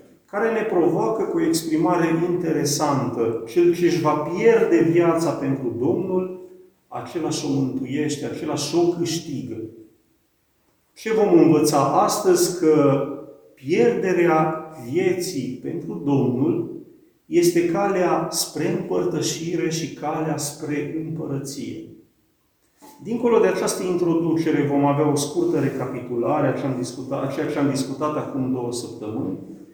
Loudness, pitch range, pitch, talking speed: -21 LUFS, 140-175 Hz, 155 Hz, 115 wpm